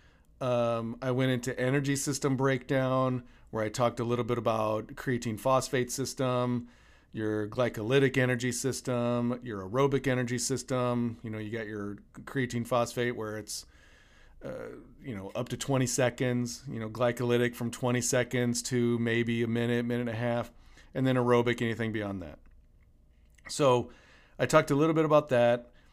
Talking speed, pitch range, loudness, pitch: 160 wpm, 115-130 Hz, -30 LUFS, 120 Hz